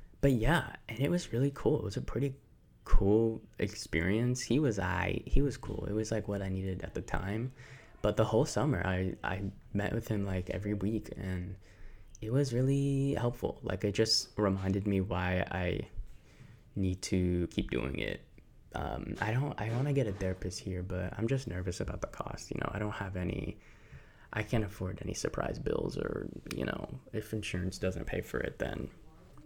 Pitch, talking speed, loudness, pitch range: 105 Hz, 195 wpm, -34 LUFS, 95-120 Hz